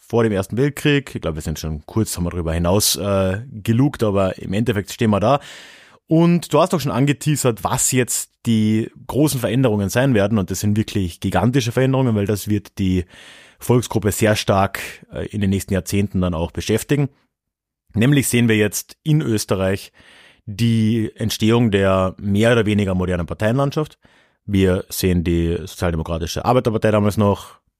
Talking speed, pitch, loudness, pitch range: 160 wpm, 105 Hz, -19 LUFS, 95-120 Hz